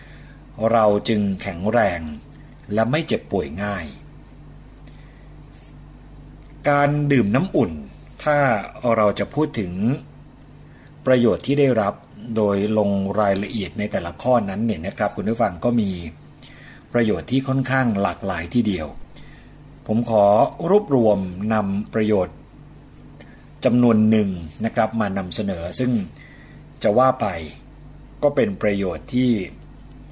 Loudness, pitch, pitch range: -21 LUFS, 110 Hz, 100-130 Hz